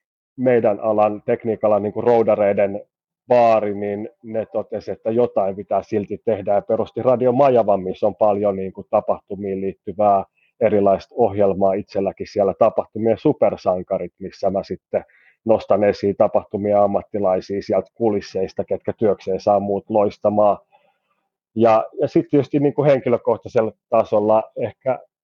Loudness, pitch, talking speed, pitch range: -19 LUFS, 105 Hz, 125 wpm, 100-115 Hz